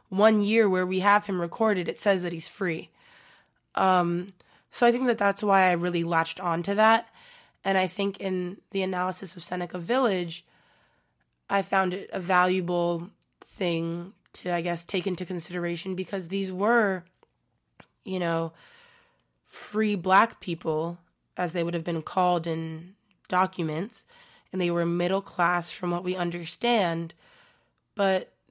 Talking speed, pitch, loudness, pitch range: 150 wpm, 185 Hz, -27 LUFS, 175-200 Hz